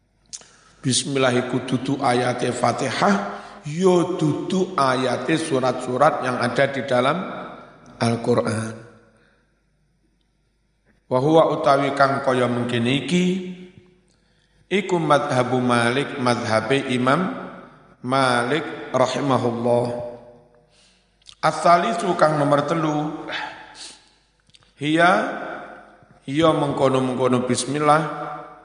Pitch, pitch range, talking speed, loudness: 135 Hz, 125-155 Hz, 75 wpm, -21 LUFS